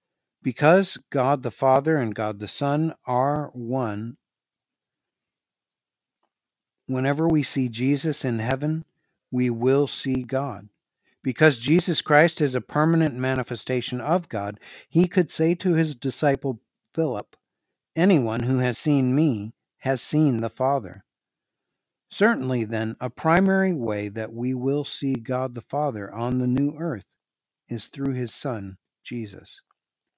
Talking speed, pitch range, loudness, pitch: 130 wpm, 120-150 Hz, -24 LUFS, 130 Hz